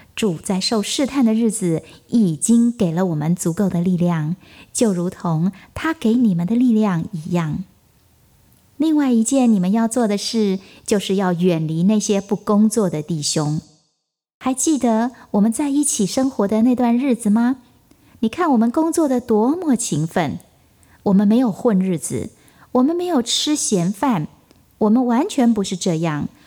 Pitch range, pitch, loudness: 175-245 Hz, 210 Hz, -19 LUFS